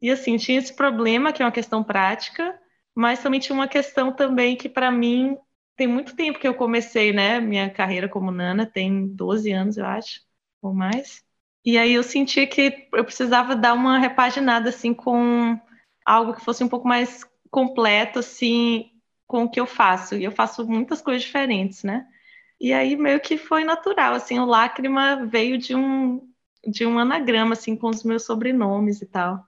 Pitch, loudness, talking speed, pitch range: 240 Hz, -21 LUFS, 185 wpm, 225-265 Hz